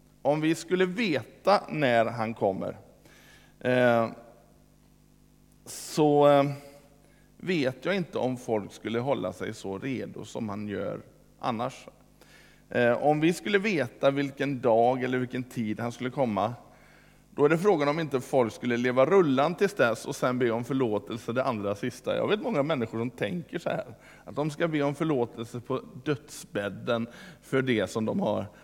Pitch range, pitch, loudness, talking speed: 115-145 Hz, 130 Hz, -28 LUFS, 155 wpm